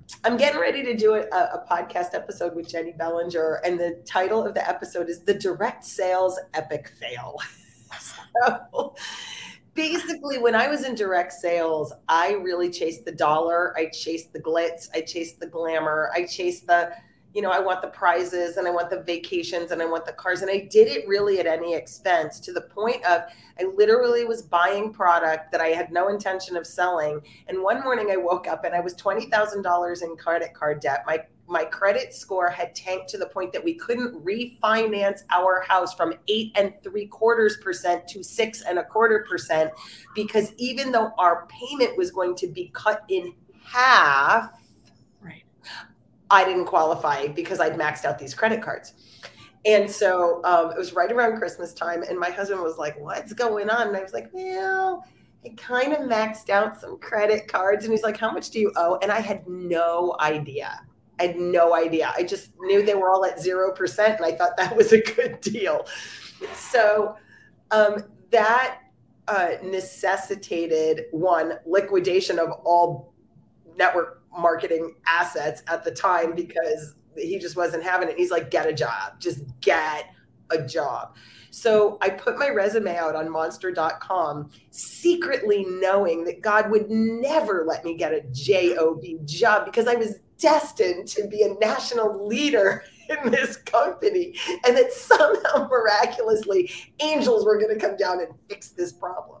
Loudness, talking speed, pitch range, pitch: -23 LUFS, 175 wpm, 170-225 Hz, 185 Hz